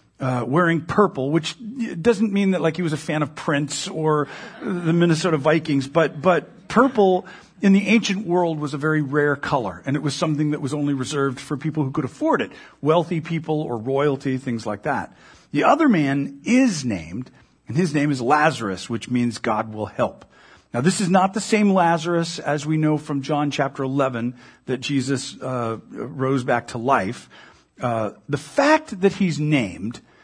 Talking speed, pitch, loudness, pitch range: 185 wpm, 155 Hz, -21 LUFS, 135-180 Hz